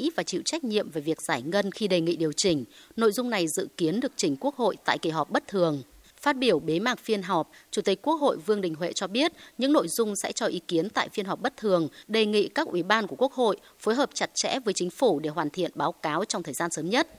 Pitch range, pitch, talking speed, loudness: 165-235 Hz, 195 Hz, 275 wpm, -27 LUFS